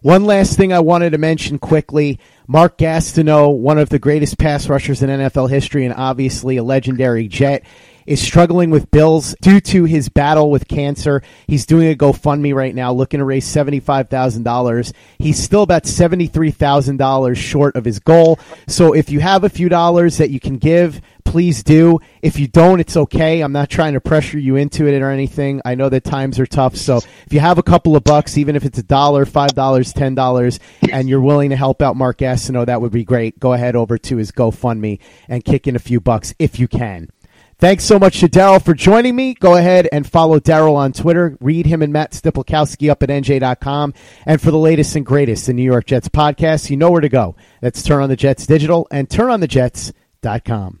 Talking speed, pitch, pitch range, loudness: 210 wpm, 145 Hz, 130-160 Hz, -13 LUFS